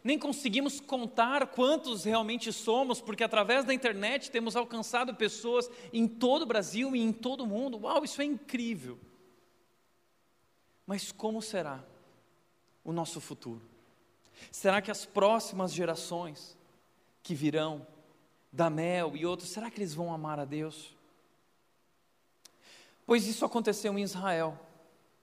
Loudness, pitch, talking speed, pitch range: -32 LUFS, 210 Hz, 130 wpm, 165-240 Hz